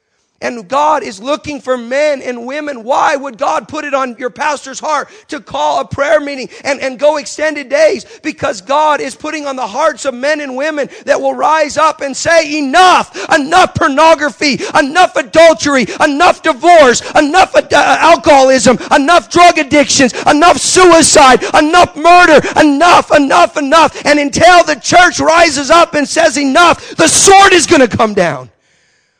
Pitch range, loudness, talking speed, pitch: 275-325 Hz, -9 LUFS, 165 wpm, 300 Hz